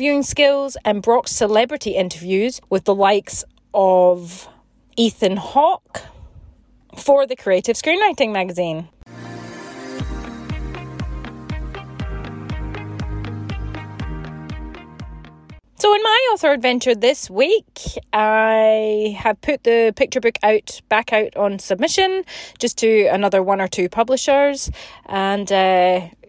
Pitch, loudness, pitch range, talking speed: 210 Hz, -17 LUFS, 180-255 Hz, 100 wpm